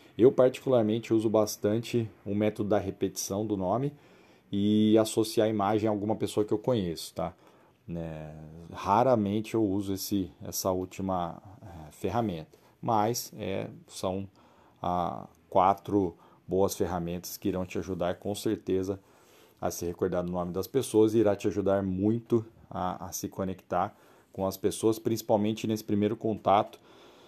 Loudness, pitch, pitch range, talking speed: -29 LUFS, 100 Hz, 95-110 Hz, 145 wpm